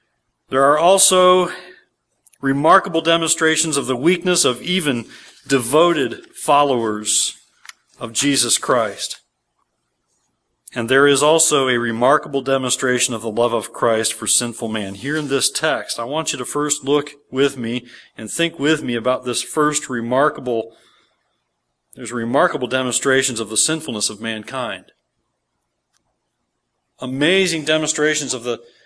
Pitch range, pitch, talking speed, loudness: 115-150 Hz, 130 Hz, 130 wpm, -17 LUFS